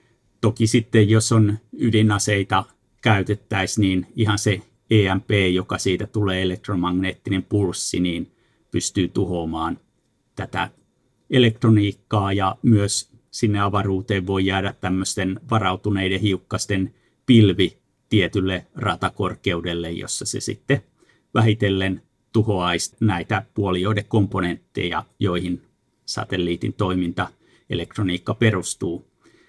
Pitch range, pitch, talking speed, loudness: 95-110 Hz, 100 Hz, 90 wpm, -21 LUFS